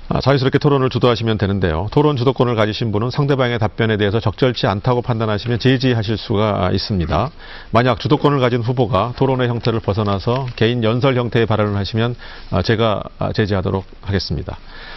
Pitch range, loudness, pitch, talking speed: 105-130 Hz, -17 LUFS, 115 Hz, 420 characters per minute